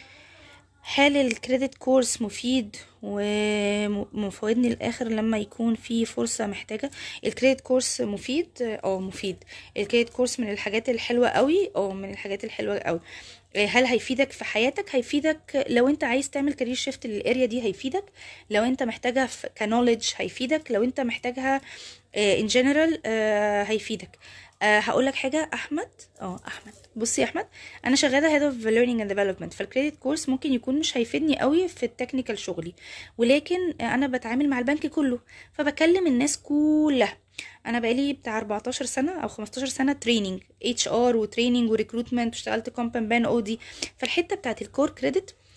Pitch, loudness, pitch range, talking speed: 245 Hz, -25 LUFS, 220-275 Hz, 145 wpm